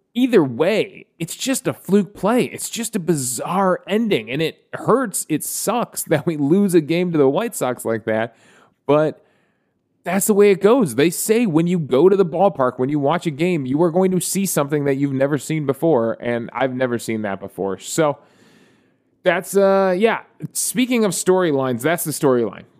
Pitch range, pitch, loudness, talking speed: 135-195 Hz, 165 Hz, -19 LUFS, 195 wpm